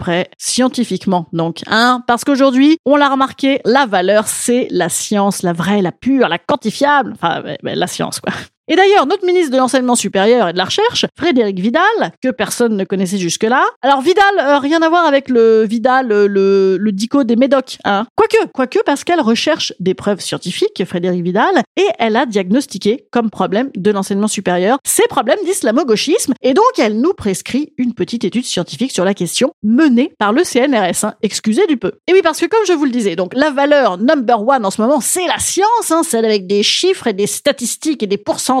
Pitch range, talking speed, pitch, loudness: 205-295 Hz, 210 wpm, 245 Hz, -14 LUFS